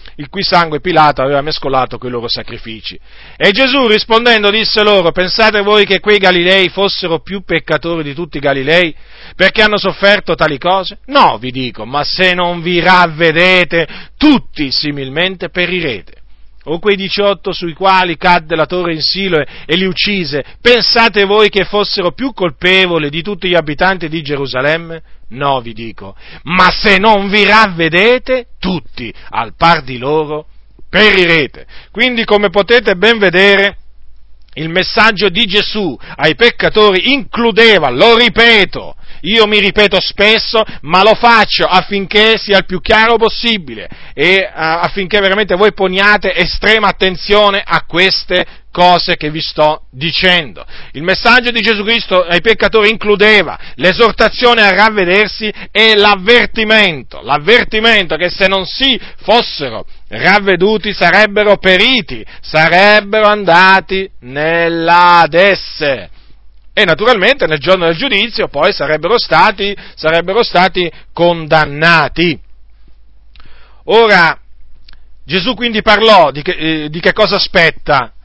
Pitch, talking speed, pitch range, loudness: 185 Hz, 130 wpm, 160-210 Hz, -10 LUFS